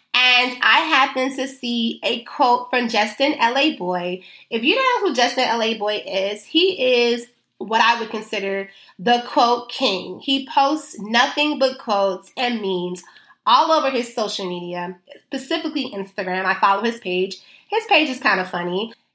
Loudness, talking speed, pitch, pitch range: -19 LUFS, 165 wpm, 235 Hz, 195-265 Hz